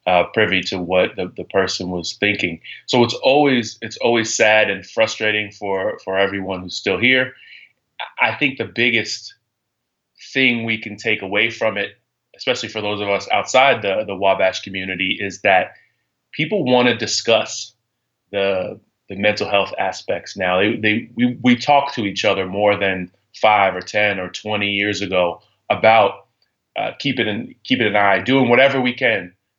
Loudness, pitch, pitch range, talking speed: -18 LUFS, 105 Hz, 95-115 Hz, 170 wpm